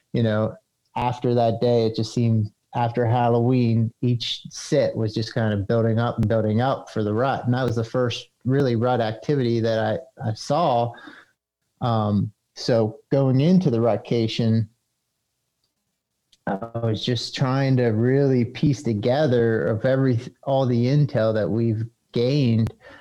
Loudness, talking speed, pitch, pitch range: -22 LUFS, 150 wpm, 120 Hz, 115-130 Hz